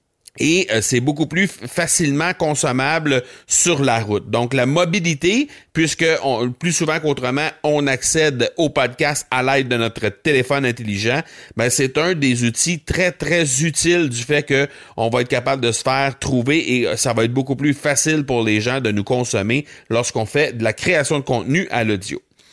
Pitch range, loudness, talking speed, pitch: 120-155 Hz, -18 LUFS, 185 wpm, 135 Hz